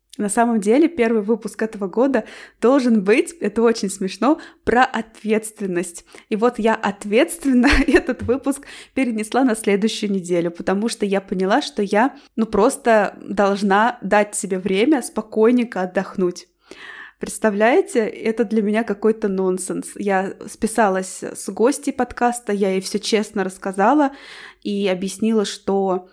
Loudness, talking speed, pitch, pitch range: -19 LUFS, 130 wpm, 220 Hz, 200-240 Hz